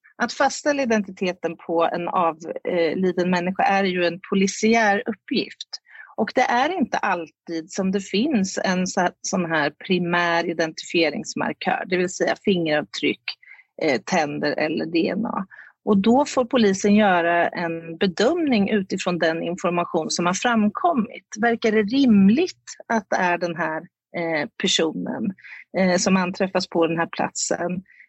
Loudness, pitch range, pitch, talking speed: -22 LUFS, 175-220 Hz, 185 Hz, 130 wpm